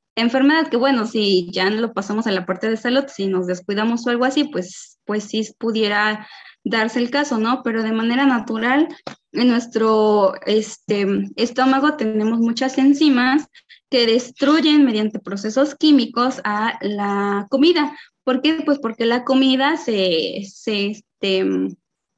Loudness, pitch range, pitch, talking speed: -19 LUFS, 210-265 Hz, 230 Hz, 150 wpm